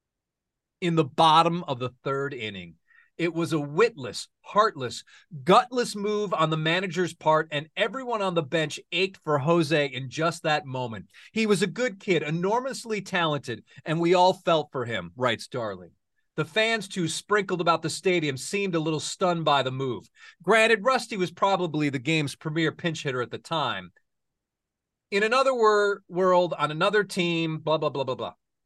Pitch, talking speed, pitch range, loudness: 170 Hz, 175 wpm, 150-195 Hz, -25 LUFS